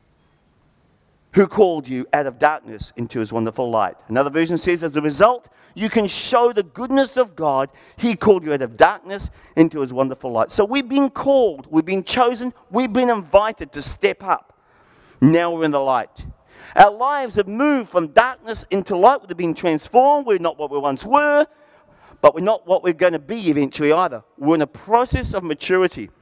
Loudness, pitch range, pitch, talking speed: -19 LUFS, 150-235 Hz, 185 Hz, 190 wpm